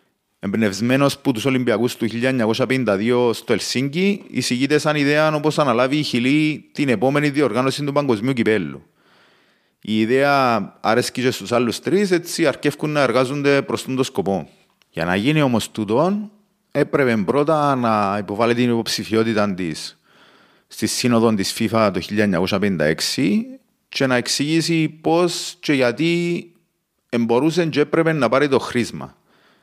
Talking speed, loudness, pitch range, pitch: 135 wpm, -19 LUFS, 120-155 Hz, 135 Hz